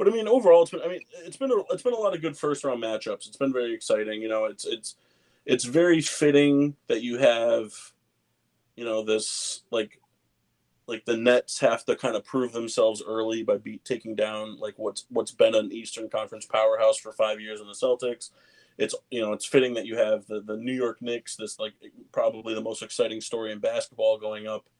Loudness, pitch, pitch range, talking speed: -26 LUFS, 120 Hz, 110-165 Hz, 210 wpm